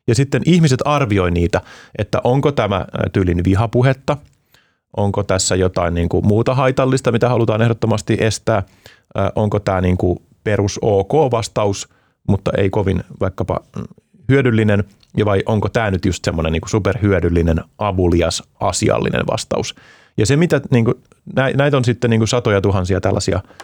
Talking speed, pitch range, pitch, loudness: 145 wpm, 95-120 Hz, 105 Hz, -17 LUFS